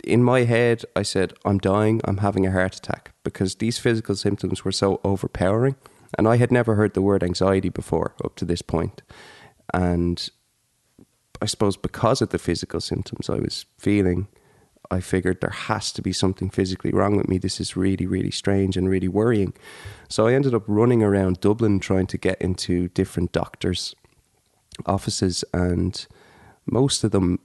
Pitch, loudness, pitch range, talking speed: 95 Hz, -23 LUFS, 90-110 Hz, 175 wpm